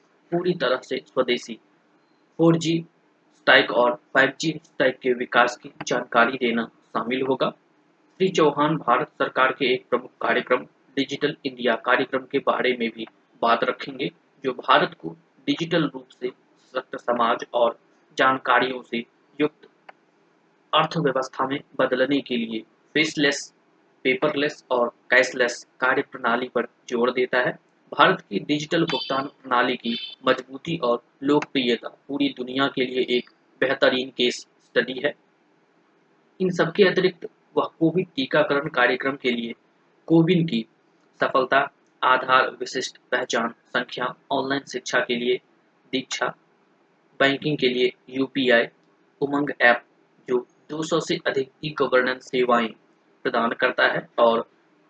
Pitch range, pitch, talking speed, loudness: 125-150 Hz, 135 Hz, 130 wpm, -23 LUFS